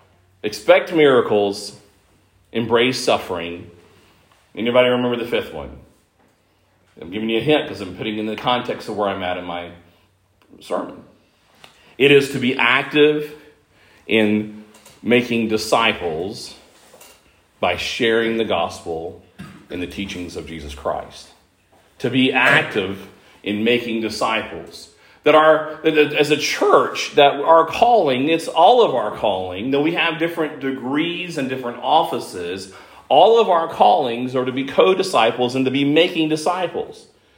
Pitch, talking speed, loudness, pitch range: 120 Hz, 135 wpm, -18 LUFS, 100-150 Hz